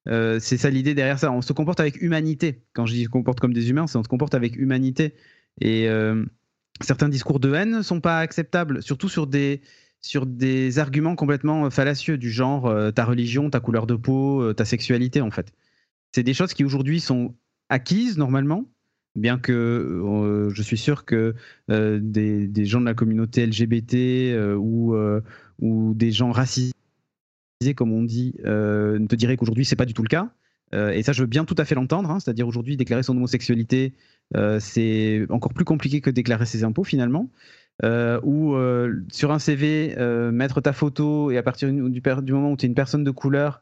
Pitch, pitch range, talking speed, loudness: 130 Hz, 115-145 Hz, 205 wpm, -22 LUFS